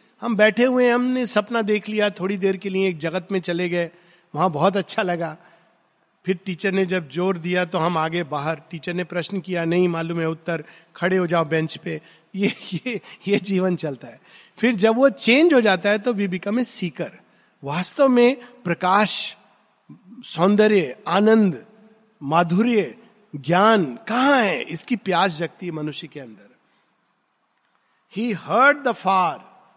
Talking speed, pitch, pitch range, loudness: 160 wpm, 190 Hz, 175-220 Hz, -21 LUFS